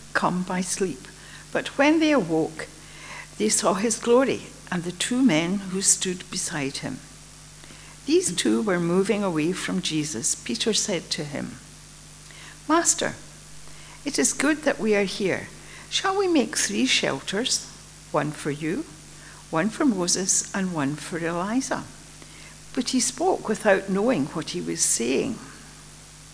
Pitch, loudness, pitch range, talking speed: 190 Hz, -24 LUFS, 165-240 Hz, 140 wpm